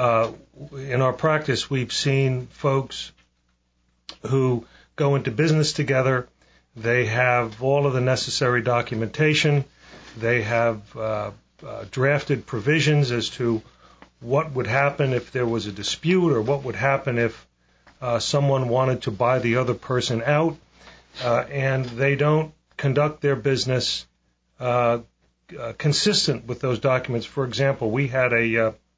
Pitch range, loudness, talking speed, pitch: 115-140 Hz, -22 LUFS, 140 wpm, 130 Hz